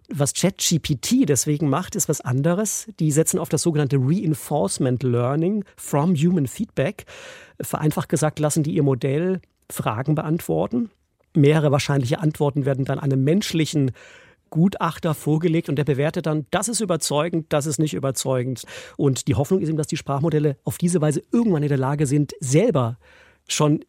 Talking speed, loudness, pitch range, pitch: 160 wpm, -22 LUFS, 145-170 Hz, 155 Hz